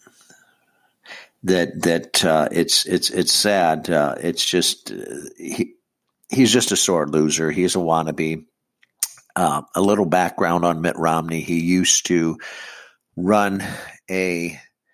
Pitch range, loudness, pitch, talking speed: 80-90 Hz, -19 LUFS, 85 Hz, 130 wpm